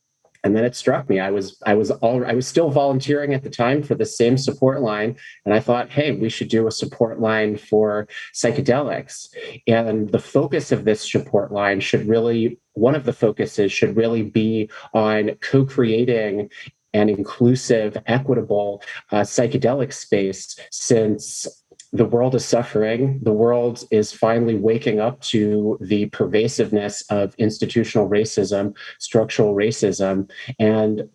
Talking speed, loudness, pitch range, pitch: 150 wpm, -20 LUFS, 105-120 Hz, 110 Hz